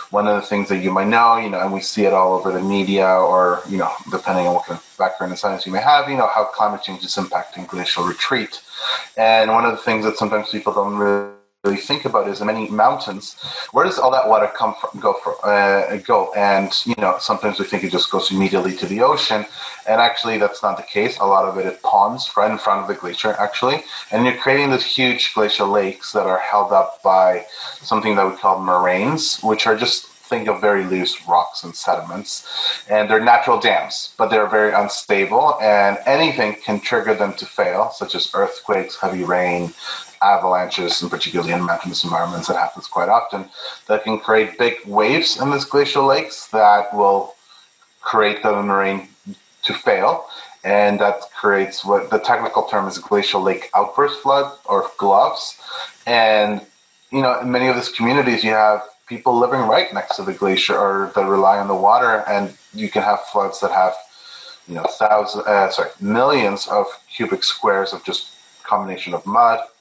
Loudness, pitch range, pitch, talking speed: -18 LUFS, 95-110 Hz, 105 Hz, 200 wpm